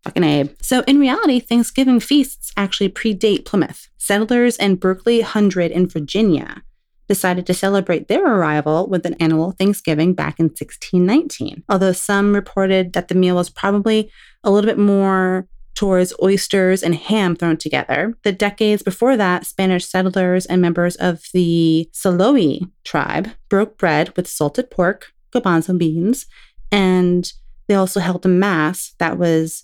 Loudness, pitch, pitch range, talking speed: -17 LUFS, 190 Hz, 175-205 Hz, 150 wpm